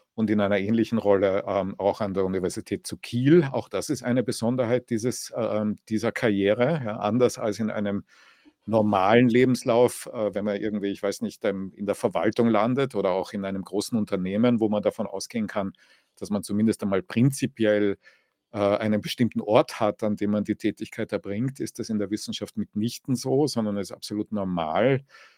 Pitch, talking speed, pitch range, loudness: 105 Hz, 185 wpm, 100-120 Hz, -25 LUFS